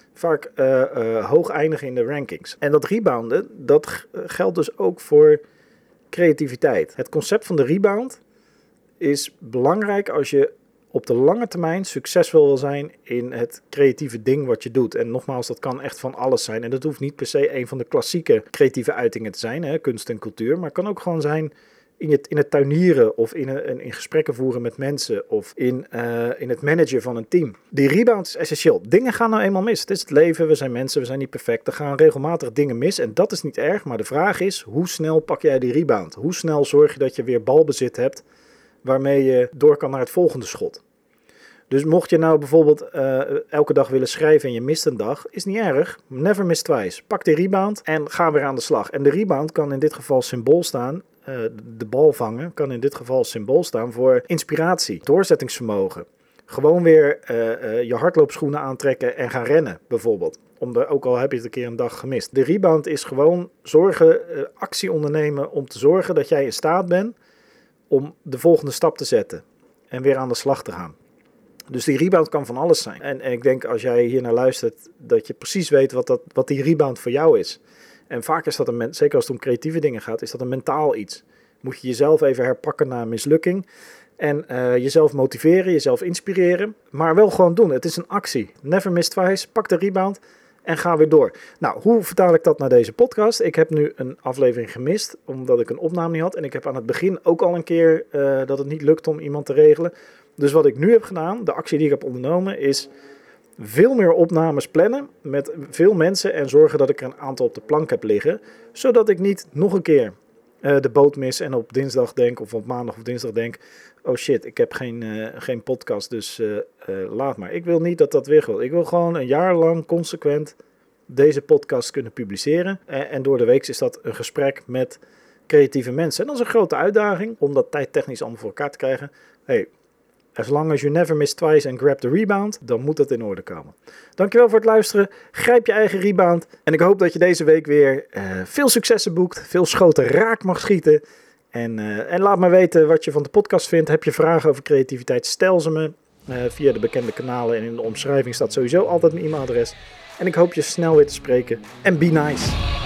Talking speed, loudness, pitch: 225 wpm, -19 LUFS, 170 Hz